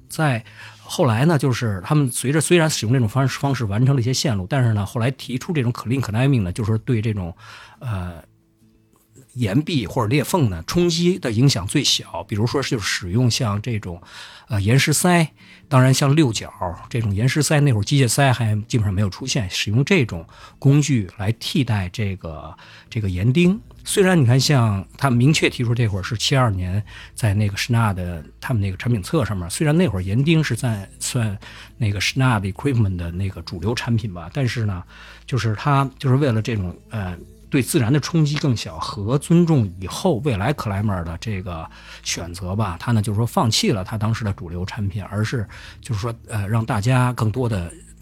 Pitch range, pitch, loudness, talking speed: 100-135 Hz, 115 Hz, -20 LUFS, 320 characters per minute